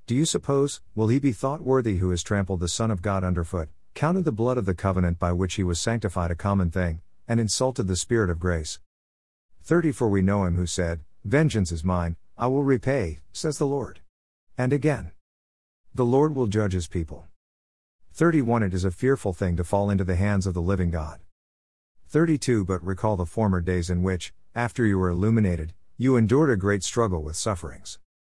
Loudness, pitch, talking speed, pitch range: -25 LUFS, 95 Hz, 195 wpm, 85-120 Hz